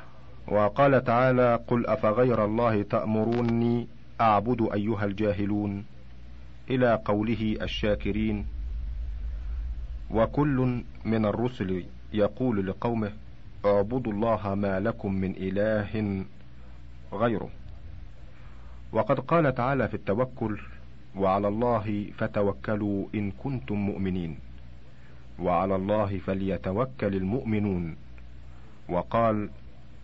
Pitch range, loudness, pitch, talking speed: 75-115 Hz, -27 LUFS, 100 Hz, 80 wpm